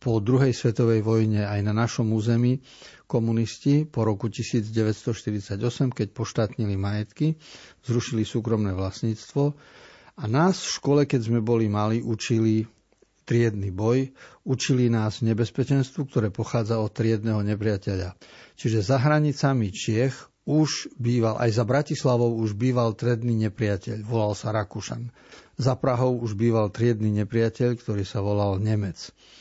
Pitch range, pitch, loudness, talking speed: 110-125 Hz, 115 Hz, -25 LUFS, 130 wpm